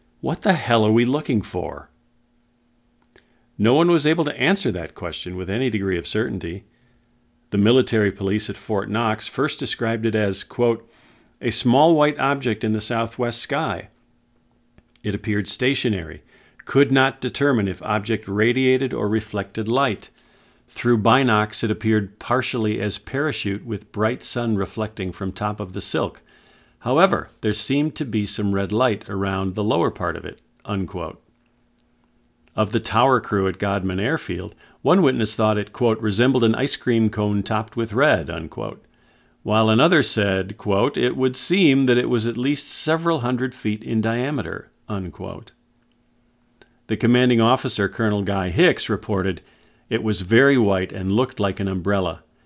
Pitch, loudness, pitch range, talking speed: 110 Hz, -21 LUFS, 100-125 Hz, 155 wpm